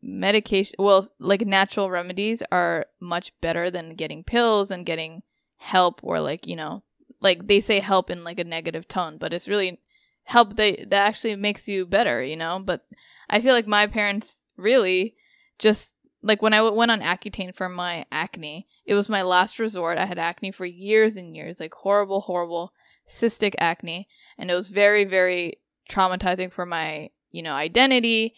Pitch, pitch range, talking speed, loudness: 195 Hz, 180-215 Hz, 180 wpm, -22 LUFS